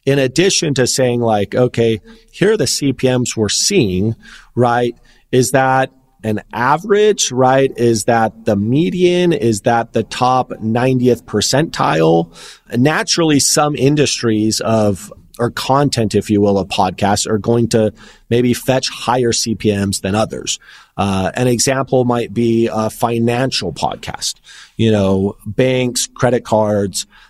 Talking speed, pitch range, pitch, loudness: 135 wpm, 110-130 Hz, 120 Hz, -15 LUFS